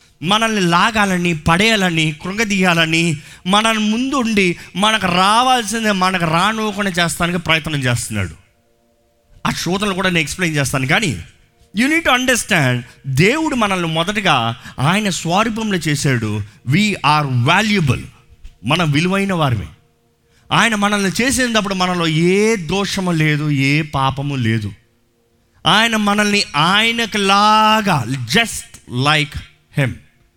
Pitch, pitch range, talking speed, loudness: 175 Hz, 135-210 Hz, 100 wpm, -15 LUFS